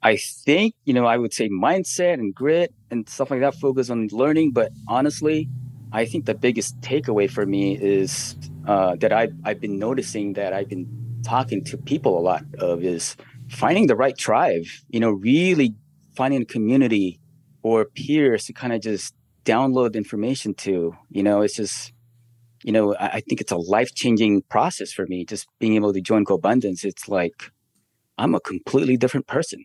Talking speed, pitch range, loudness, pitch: 185 wpm, 105-135 Hz, -22 LUFS, 120 Hz